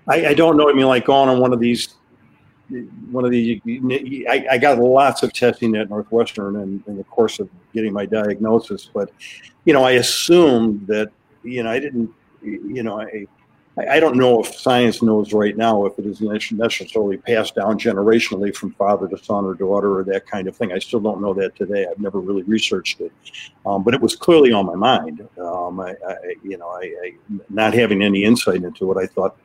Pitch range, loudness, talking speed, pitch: 105-125 Hz, -18 LUFS, 215 wpm, 110 Hz